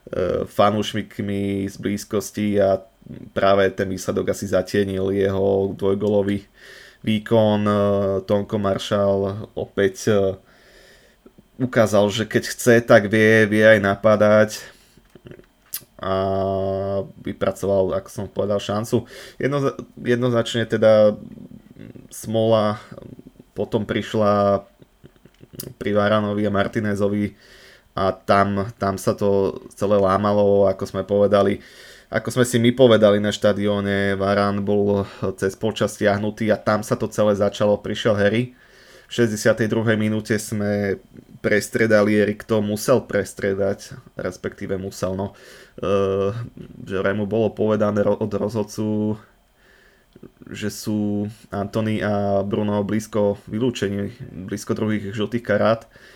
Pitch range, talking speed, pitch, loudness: 100-110 Hz, 105 wpm, 105 Hz, -20 LUFS